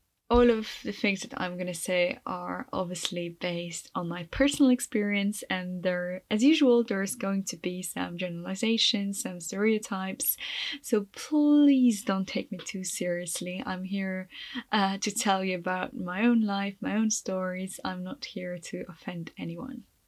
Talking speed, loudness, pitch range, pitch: 160 wpm, -29 LUFS, 180-230 Hz, 195 Hz